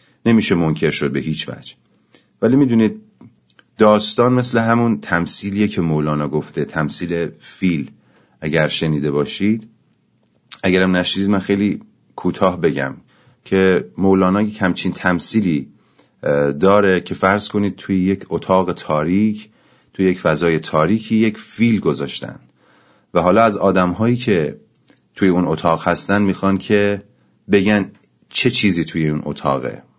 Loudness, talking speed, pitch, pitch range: -17 LUFS, 130 wpm, 95 Hz, 80-105 Hz